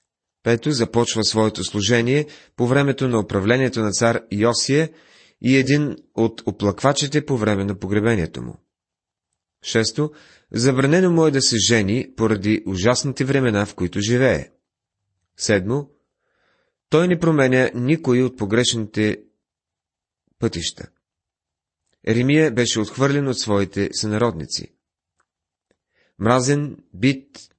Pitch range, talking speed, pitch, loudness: 105-135 Hz, 105 wpm, 120 Hz, -20 LUFS